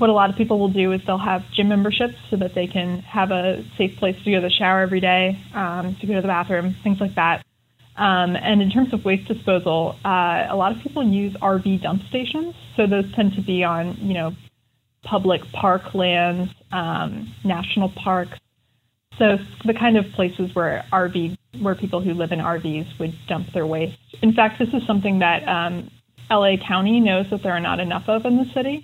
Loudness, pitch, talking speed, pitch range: -21 LUFS, 190 Hz, 215 wpm, 175-205 Hz